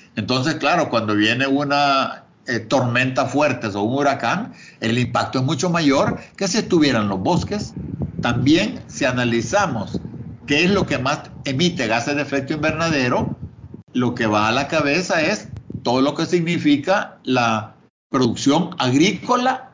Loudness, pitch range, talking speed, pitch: -19 LUFS, 120-155 Hz, 145 wpm, 140 Hz